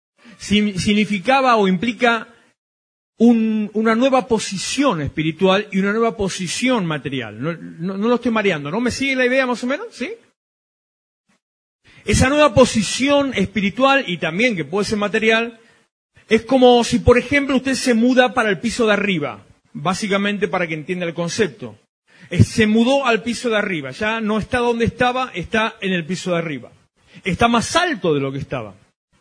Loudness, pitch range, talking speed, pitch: -18 LUFS, 185-245 Hz, 170 wpm, 220 Hz